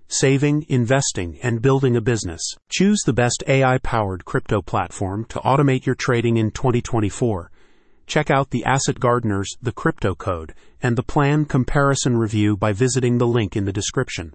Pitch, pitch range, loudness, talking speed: 120 Hz, 105-135 Hz, -20 LUFS, 165 wpm